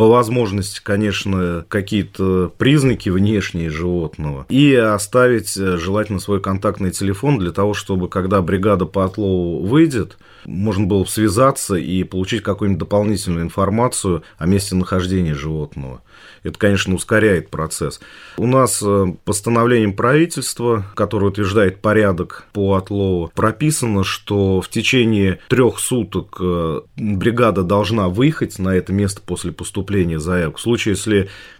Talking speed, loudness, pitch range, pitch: 125 wpm, -17 LUFS, 90-110 Hz, 100 Hz